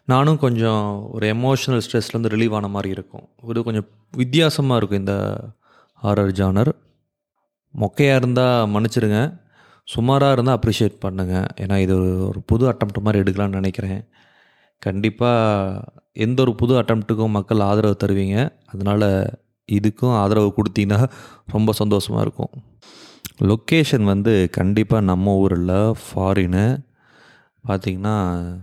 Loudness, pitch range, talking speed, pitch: -19 LUFS, 100-120 Hz, 115 wpm, 110 Hz